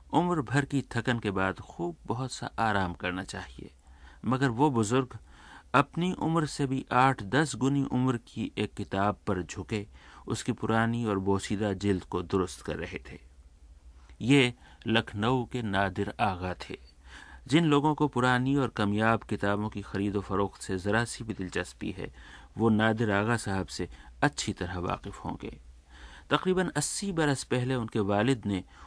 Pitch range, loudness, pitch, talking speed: 95-130 Hz, -29 LUFS, 105 Hz, 160 wpm